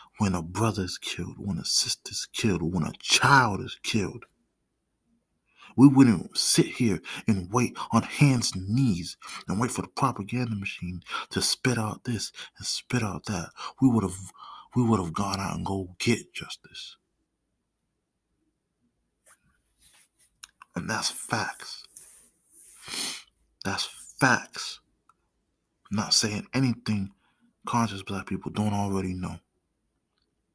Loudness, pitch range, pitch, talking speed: -26 LUFS, 95-120 Hz, 105 Hz, 130 wpm